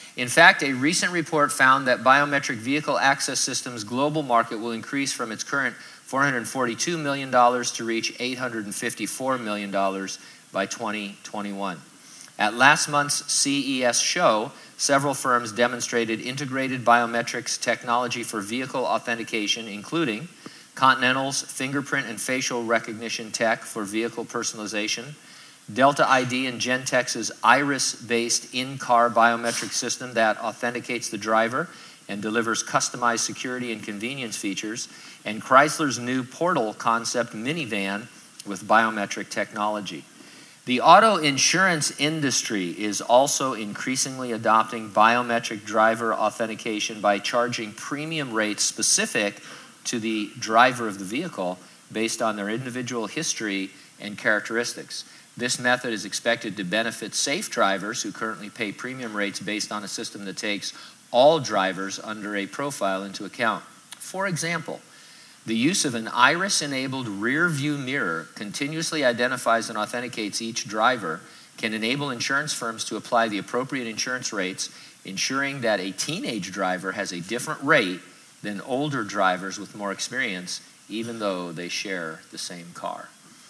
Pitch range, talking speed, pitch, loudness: 105-130 Hz, 130 wpm, 115 Hz, -24 LUFS